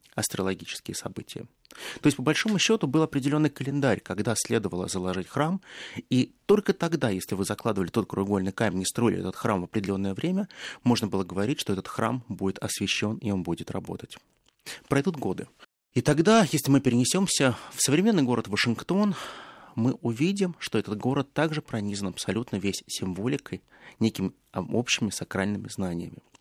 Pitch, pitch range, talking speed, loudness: 115 Hz, 100-150 Hz, 150 wpm, -27 LUFS